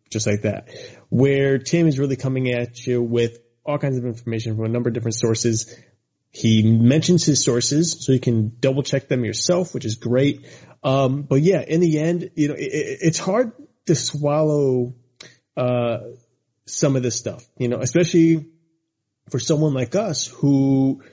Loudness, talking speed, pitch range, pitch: -20 LUFS, 175 wpm, 120-155 Hz, 135 Hz